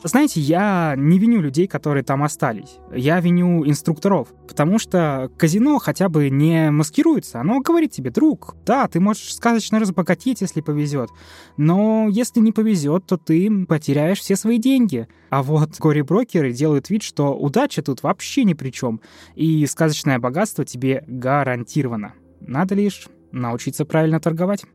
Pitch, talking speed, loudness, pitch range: 160 Hz, 150 wpm, -19 LUFS, 145-205 Hz